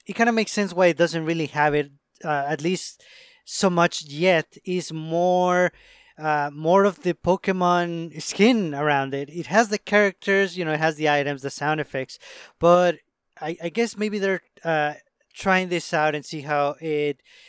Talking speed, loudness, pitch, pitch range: 185 wpm, -23 LUFS, 170 Hz, 150-190 Hz